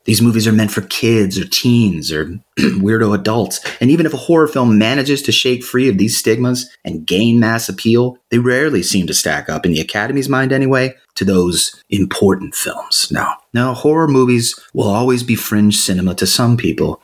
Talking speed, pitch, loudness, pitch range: 195 wpm, 120 Hz, -14 LUFS, 110-130 Hz